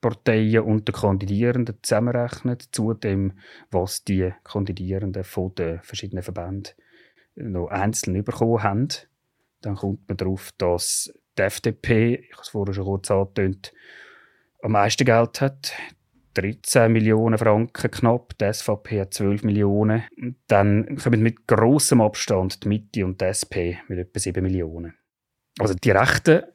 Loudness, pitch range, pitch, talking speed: -22 LUFS, 95-115 Hz, 105 Hz, 140 wpm